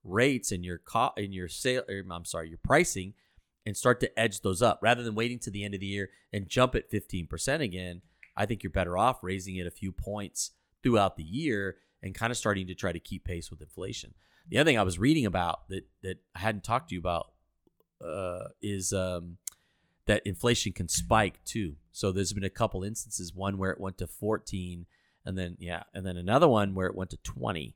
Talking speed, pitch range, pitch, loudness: 225 wpm, 90-110 Hz, 95 Hz, -30 LUFS